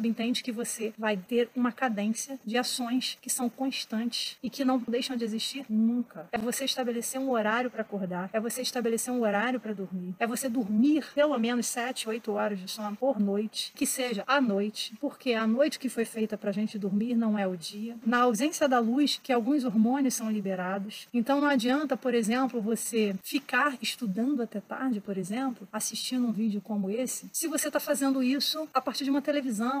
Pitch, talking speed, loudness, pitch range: 240 Hz, 195 wpm, -29 LUFS, 215-260 Hz